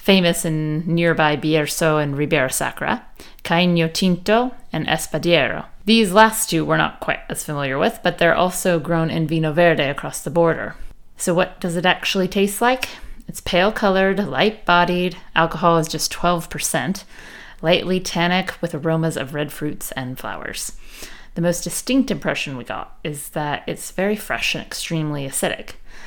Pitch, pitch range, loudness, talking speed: 170 Hz, 155-185 Hz, -19 LUFS, 160 wpm